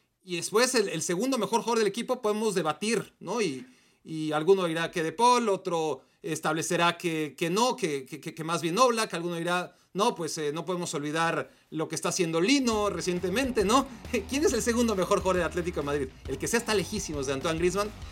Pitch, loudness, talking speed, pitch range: 180 Hz, -28 LUFS, 210 wpm, 165-220 Hz